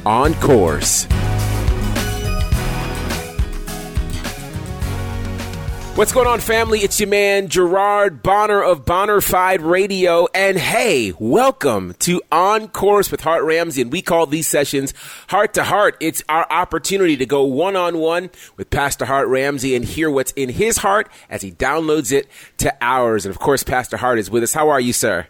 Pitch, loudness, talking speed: 140 Hz, -17 LUFS, 155 wpm